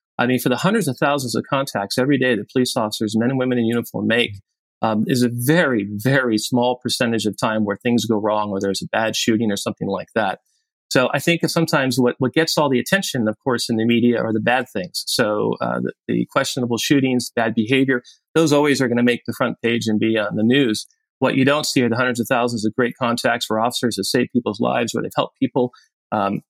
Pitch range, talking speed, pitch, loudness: 110-135 Hz, 240 wpm, 120 Hz, -19 LUFS